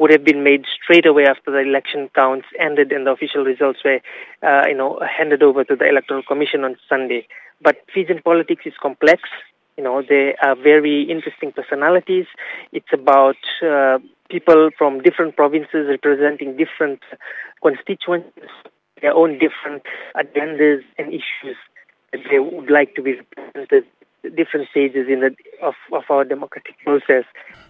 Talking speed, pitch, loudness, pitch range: 155 wpm, 150 Hz, -16 LUFS, 140-170 Hz